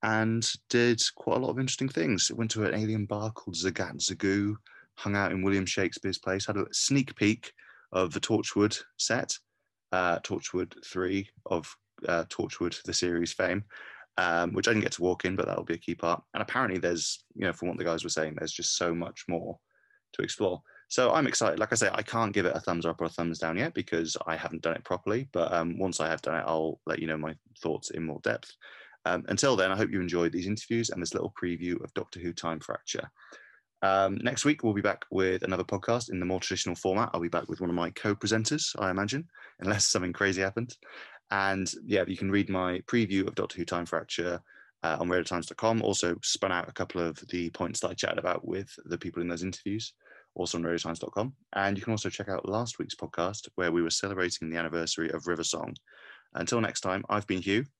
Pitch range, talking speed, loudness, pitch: 85-105 Hz, 225 wpm, -30 LUFS, 95 Hz